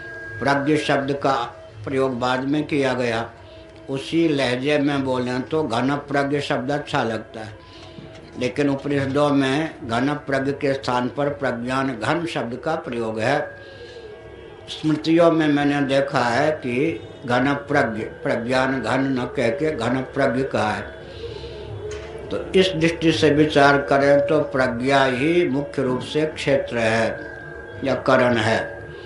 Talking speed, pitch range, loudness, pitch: 135 wpm, 125-145 Hz, -21 LUFS, 135 Hz